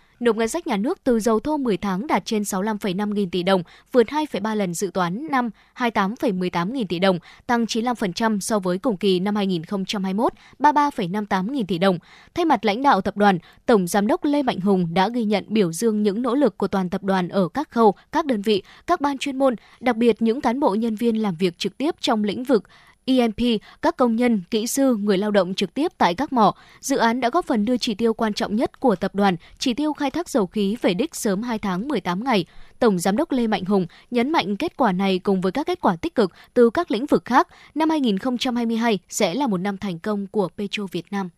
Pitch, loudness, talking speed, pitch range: 220 Hz, -22 LUFS, 235 wpm, 200-255 Hz